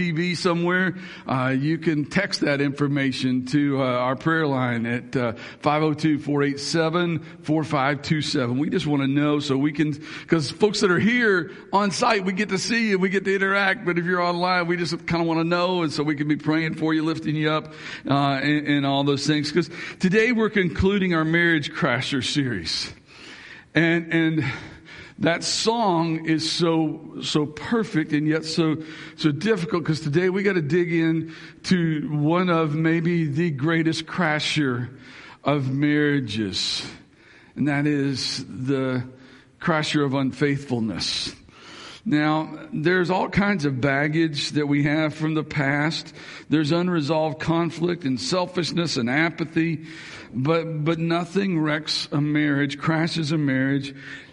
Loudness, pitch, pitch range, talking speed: -23 LUFS, 155 Hz, 145-170 Hz, 155 wpm